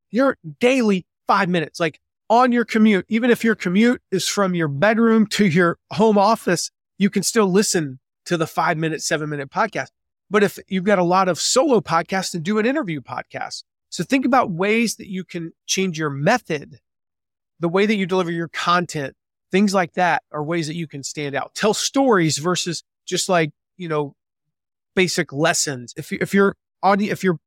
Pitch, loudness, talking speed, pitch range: 185 Hz, -20 LUFS, 190 wpm, 160-205 Hz